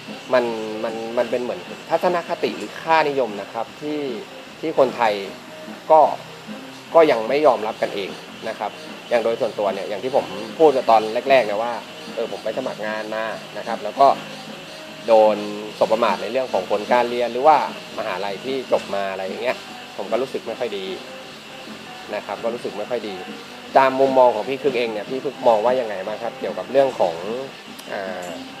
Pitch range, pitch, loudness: 110-135 Hz, 120 Hz, -21 LUFS